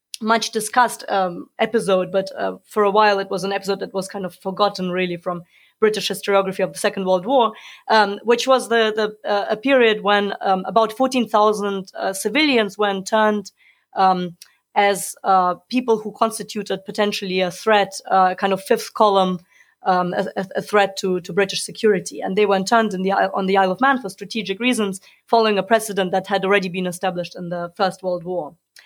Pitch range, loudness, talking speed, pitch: 190-215 Hz, -20 LUFS, 195 wpm, 200 Hz